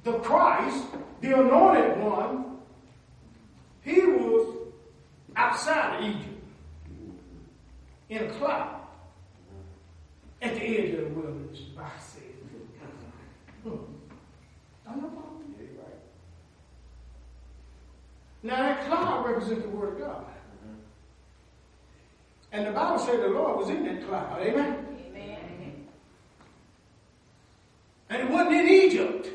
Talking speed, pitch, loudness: 90 wpm, 150 Hz, -26 LUFS